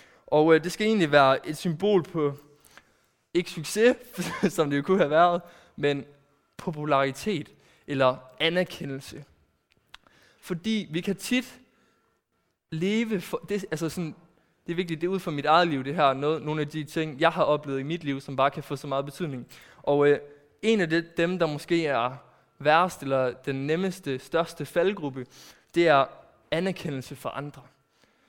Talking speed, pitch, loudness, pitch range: 170 wpm, 155 Hz, -26 LUFS, 140-175 Hz